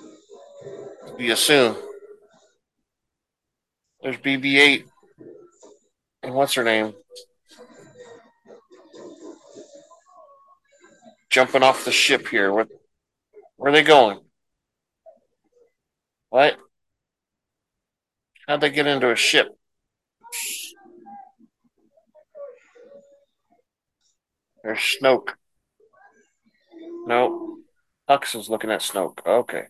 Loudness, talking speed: -19 LUFS, 70 wpm